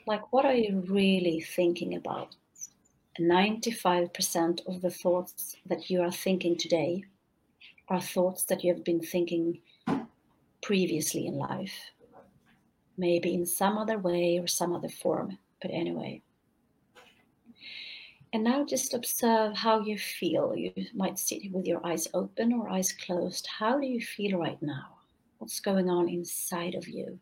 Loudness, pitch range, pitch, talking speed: -30 LUFS, 175-215 Hz, 180 Hz, 150 wpm